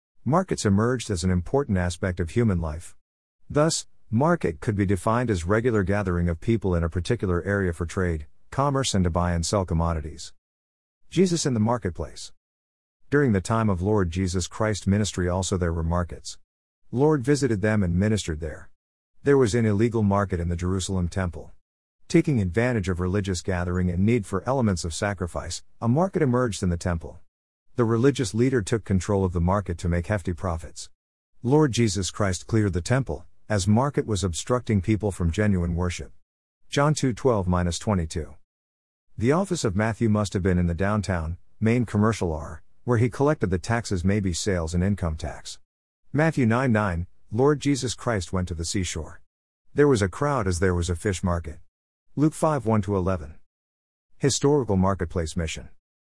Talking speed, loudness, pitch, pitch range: 170 wpm, -25 LUFS, 95 Hz, 85-115 Hz